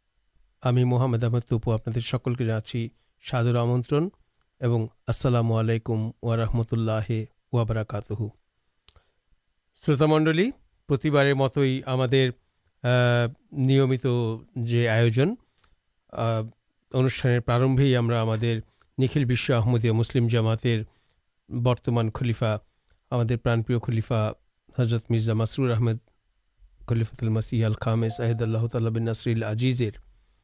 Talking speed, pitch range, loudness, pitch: 90 wpm, 115-125 Hz, -25 LUFS, 120 Hz